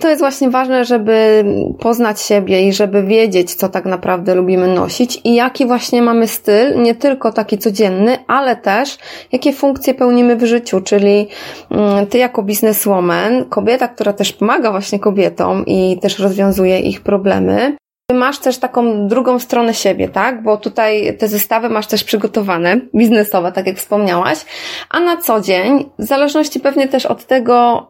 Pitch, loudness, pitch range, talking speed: 225 Hz, -13 LUFS, 200-250 Hz, 165 wpm